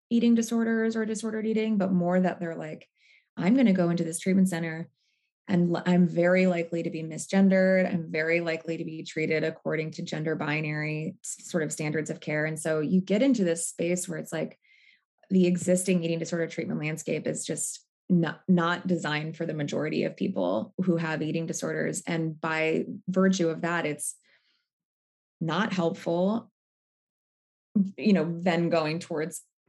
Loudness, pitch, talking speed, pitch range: -27 LUFS, 170 Hz, 170 wpm, 160-185 Hz